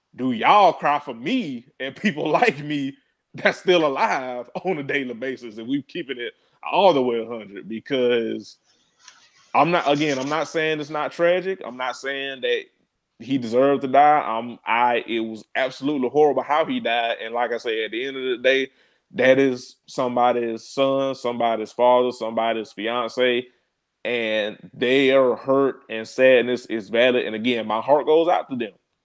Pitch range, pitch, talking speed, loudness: 120-150 Hz, 130 Hz, 175 wpm, -21 LUFS